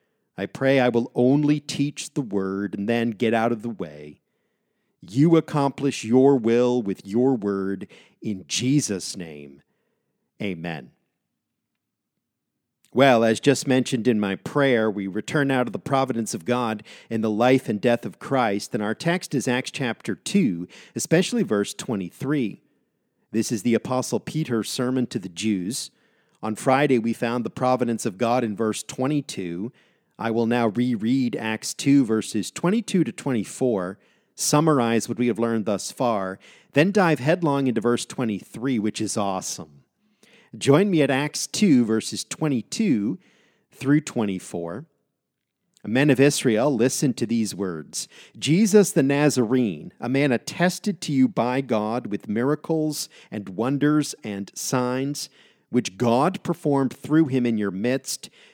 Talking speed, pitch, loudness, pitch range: 150 wpm, 125 Hz, -23 LUFS, 110-145 Hz